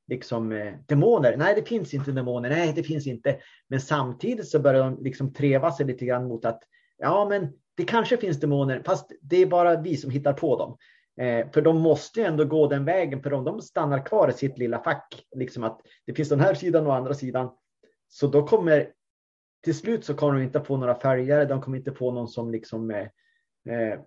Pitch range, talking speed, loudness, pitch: 125-155 Hz, 220 wpm, -25 LUFS, 140 Hz